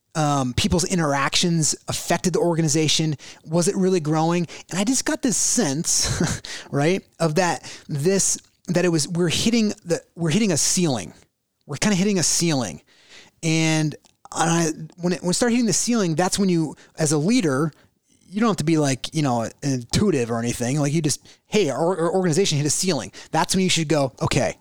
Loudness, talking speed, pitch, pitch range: -21 LUFS, 195 wpm, 165 Hz, 150-185 Hz